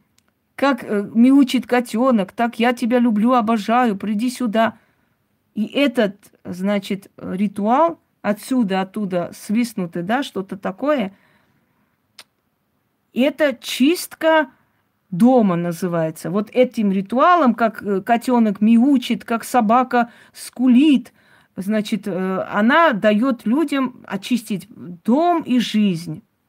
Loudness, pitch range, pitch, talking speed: -18 LUFS, 205-255 Hz, 235 Hz, 95 wpm